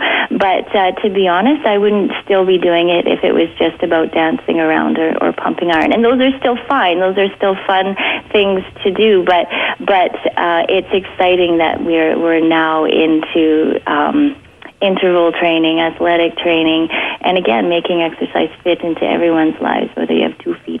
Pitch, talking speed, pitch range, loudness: 175 Hz, 180 wpm, 165-200 Hz, -14 LUFS